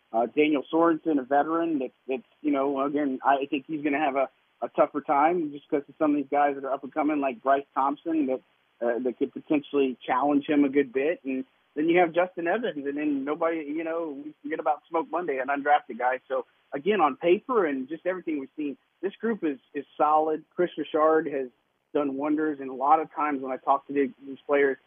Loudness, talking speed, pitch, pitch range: -27 LUFS, 225 wpm, 145 Hz, 135-160 Hz